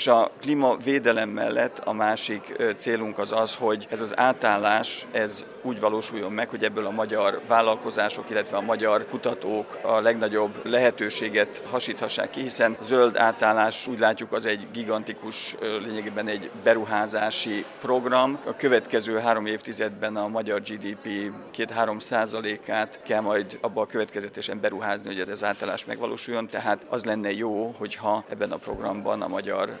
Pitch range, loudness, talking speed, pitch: 105-115 Hz, -25 LUFS, 150 wpm, 110 Hz